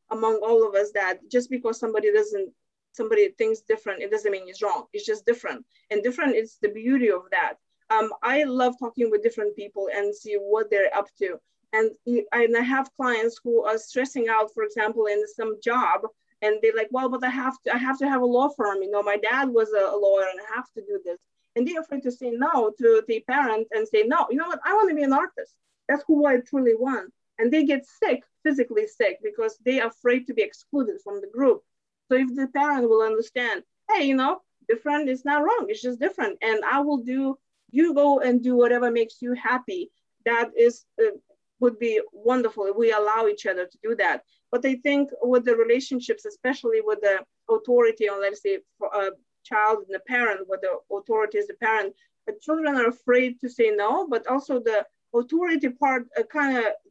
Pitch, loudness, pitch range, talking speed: 250 Hz, -24 LUFS, 220-310 Hz, 215 wpm